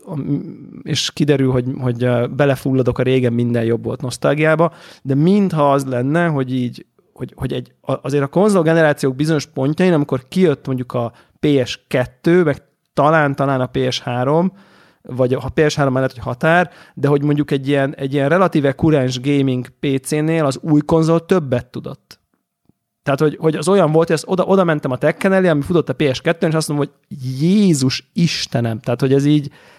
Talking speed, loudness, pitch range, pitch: 170 wpm, -17 LUFS, 130-160 Hz, 145 Hz